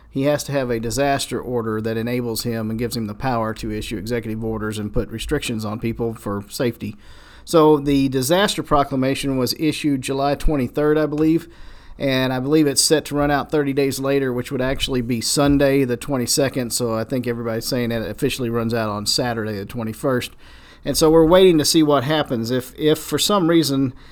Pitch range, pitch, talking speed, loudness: 115-145 Hz, 130 Hz, 200 wpm, -20 LUFS